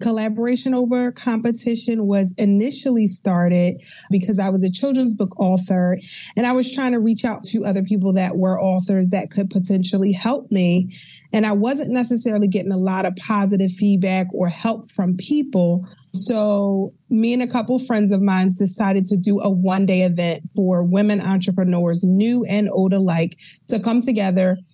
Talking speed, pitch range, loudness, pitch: 170 wpm, 185-225 Hz, -19 LUFS, 200 Hz